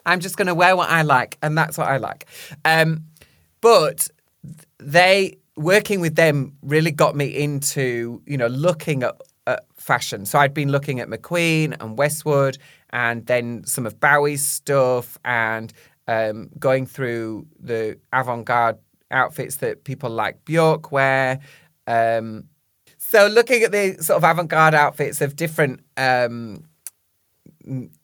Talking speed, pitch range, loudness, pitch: 145 wpm, 120-160 Hz, -19 LUFS, 145 Hz